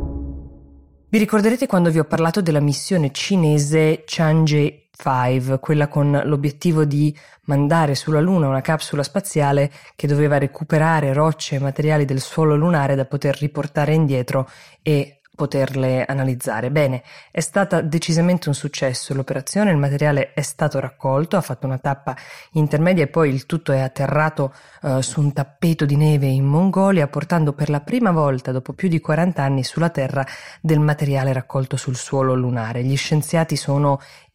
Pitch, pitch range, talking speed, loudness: 145 Hz, 135-160 Hz, 155 wpm, -19 LUFS